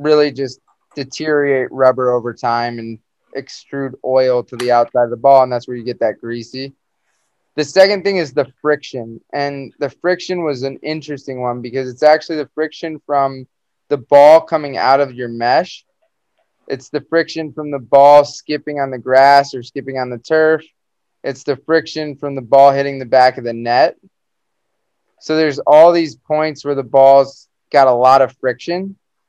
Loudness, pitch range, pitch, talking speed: -14 LUFS, 130-150 Hz, 140 Hz, 180 wpm